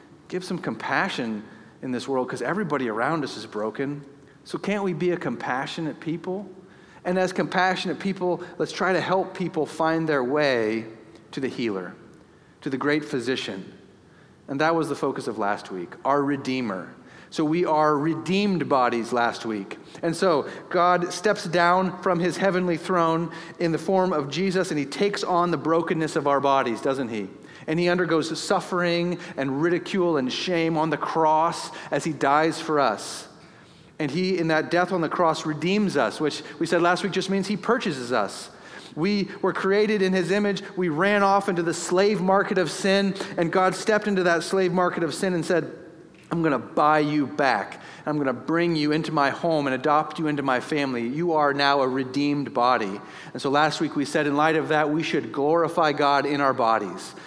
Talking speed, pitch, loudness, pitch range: 195 wpm, 160 Hz, -24 LUFS, 145-180 Hz